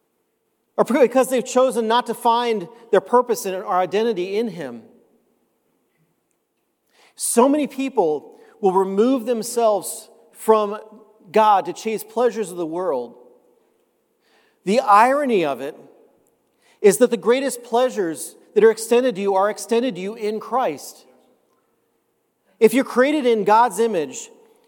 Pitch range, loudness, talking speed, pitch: 210-255 Hz, -19 LUFS, 130 wpm, 230 Hz